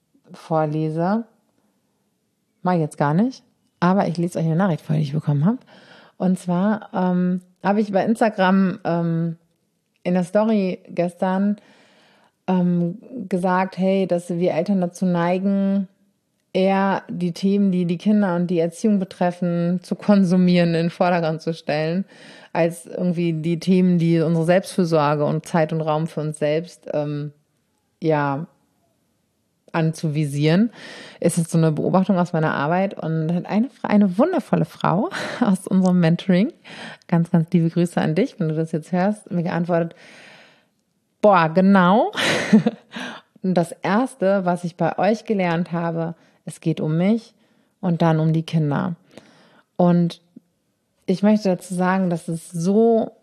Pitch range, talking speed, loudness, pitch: 165-200 Hz, 145 wpm, -20 LUFS, 180 Hz